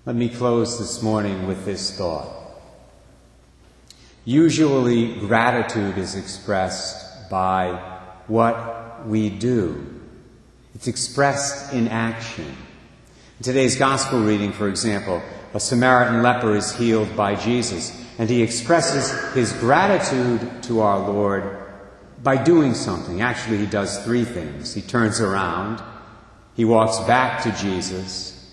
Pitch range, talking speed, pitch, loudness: 100-120 Hz, 120 wpm, 115 Hz, -21 LUFS